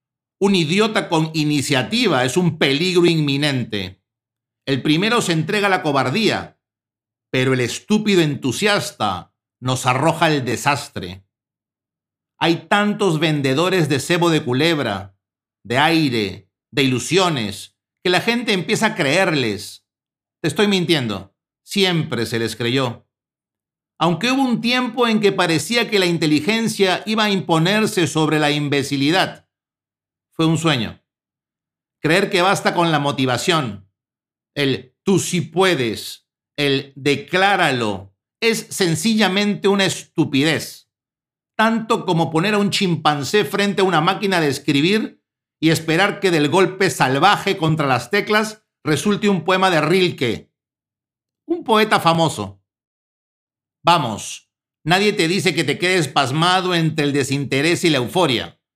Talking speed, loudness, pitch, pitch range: 130 wpm, -18 LUFS, 155 Hz, 130-190 Hz